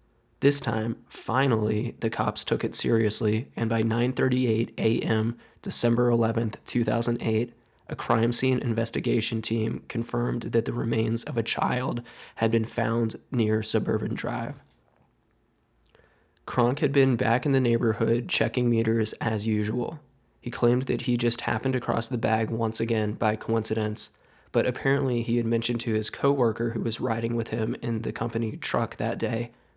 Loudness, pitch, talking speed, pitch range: -26 LUFS, 115 Hz, 155 wpm, 110-120 Hz